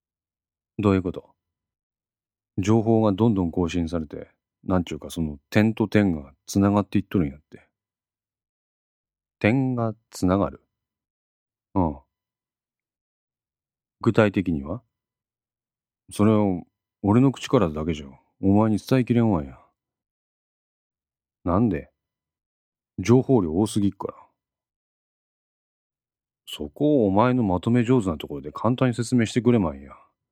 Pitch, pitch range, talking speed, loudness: 105 Hz, 90-115 Hz, 235 characters per minute, -23 LUFS